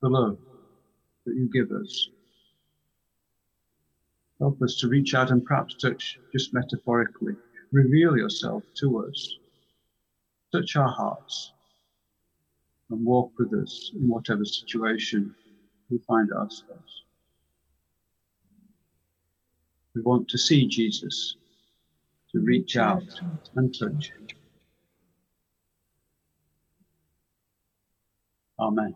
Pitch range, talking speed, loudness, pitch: 75-125 Hz, 95 wpm, -26 LUFS, 105 Hz